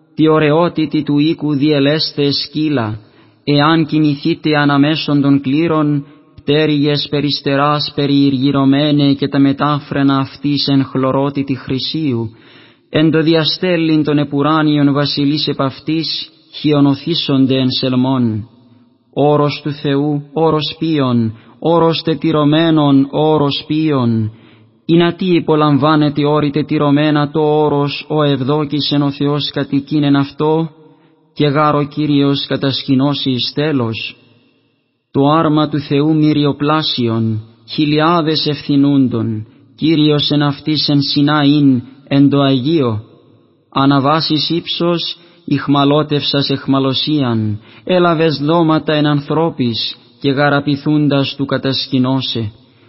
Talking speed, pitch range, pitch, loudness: 105 wpm, 135-155 Hz, 145 Hz, -14 LUFS